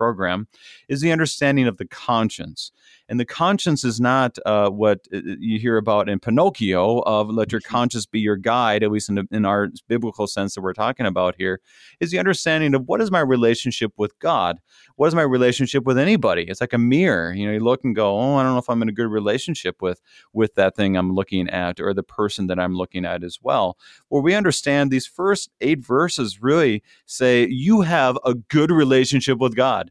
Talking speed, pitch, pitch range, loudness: 215 wpm, 120 Hz, 100-130 Hz, -20 LUFS